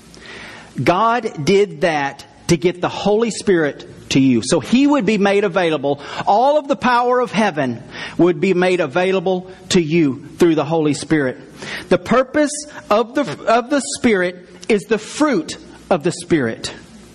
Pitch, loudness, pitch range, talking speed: 185 Hz, -17 LUFS, 160-230 Hz, 160 wpm